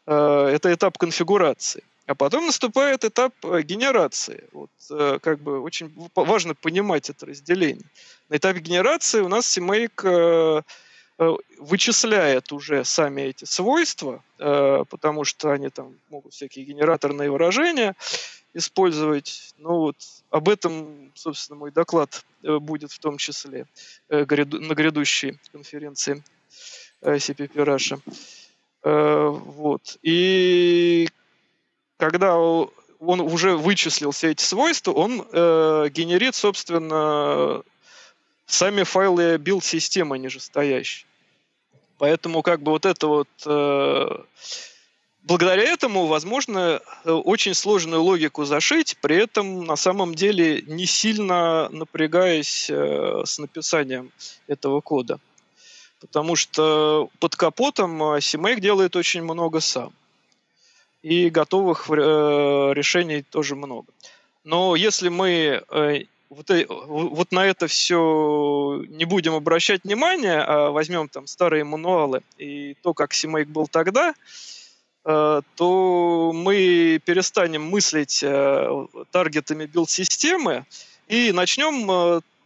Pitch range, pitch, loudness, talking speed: 150-185 Hz, 165 Hz, -21 LUFS, 105 wpm